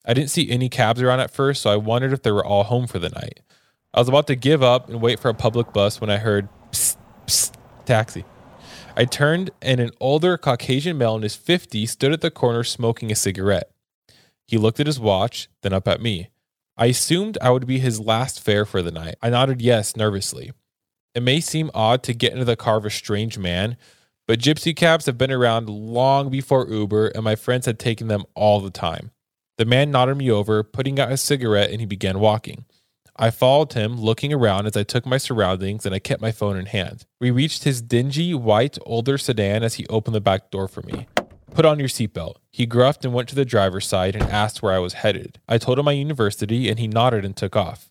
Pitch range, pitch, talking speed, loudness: 105-130 Hz, 115 Hz, 230 wpm, -20 LUFS